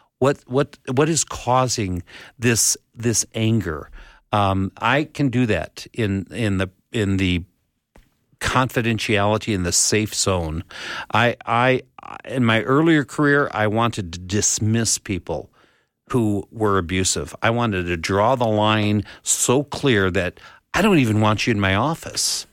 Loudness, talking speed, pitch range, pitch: -20 LUFS, 145 wpm, 95-125 Hz, 110 Hz